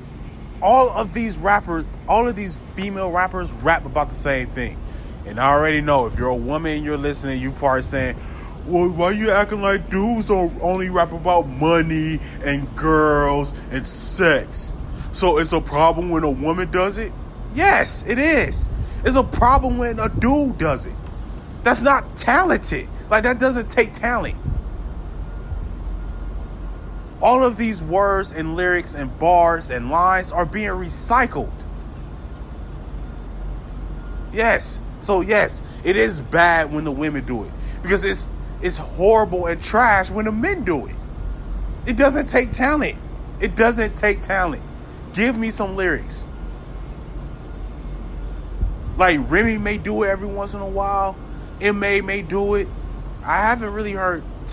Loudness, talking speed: -19 LUFS, 150 wpm